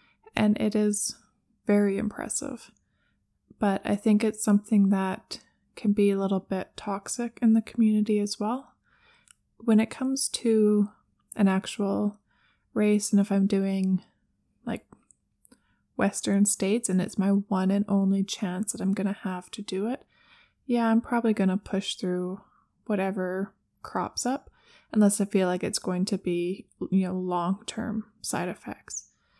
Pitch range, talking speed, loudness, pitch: 195-220 Hz, 155 wpm, -27 LUFS, 205 Hz